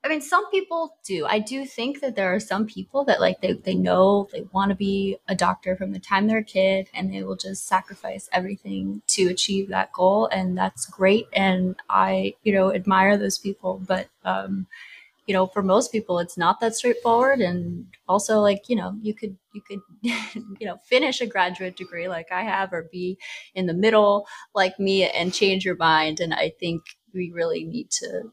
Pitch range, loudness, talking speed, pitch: 180-215 Hz, -23 LUFS, 205 wpm, 190 Hz